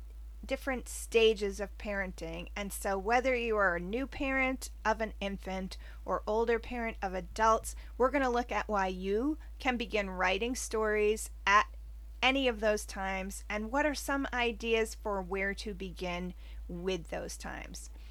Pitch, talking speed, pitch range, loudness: 210 Hz, 160 wpm, 190-240 Hz, -33 LUFS